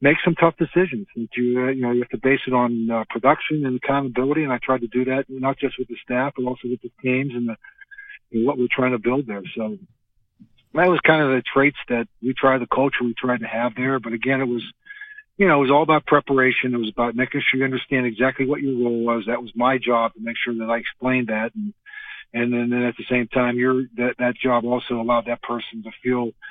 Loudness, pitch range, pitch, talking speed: -21 LUFS, 120-135 Hz, 125 Hz, 255 wpm